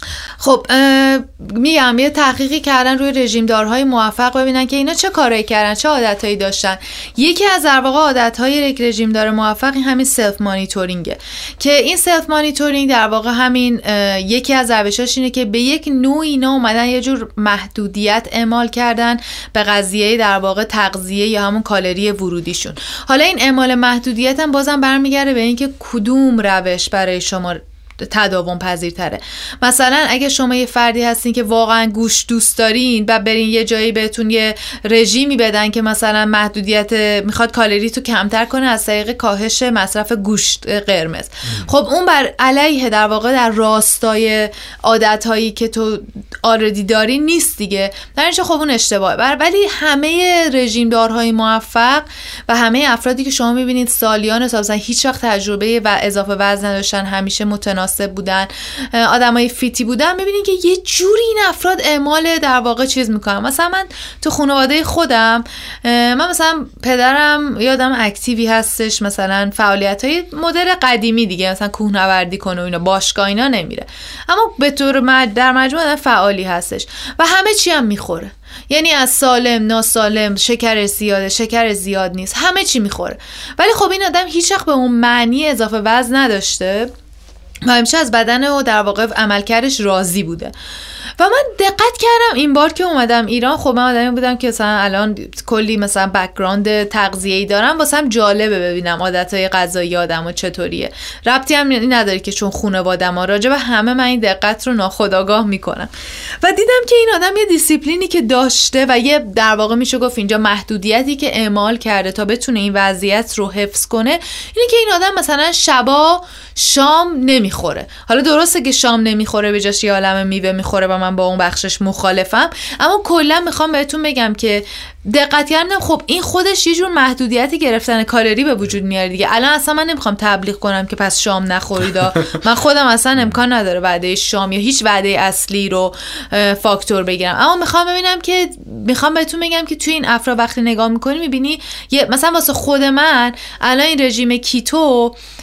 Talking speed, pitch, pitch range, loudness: 165 wpm, 235 Hz, 205-275 Hz, -13 LUFS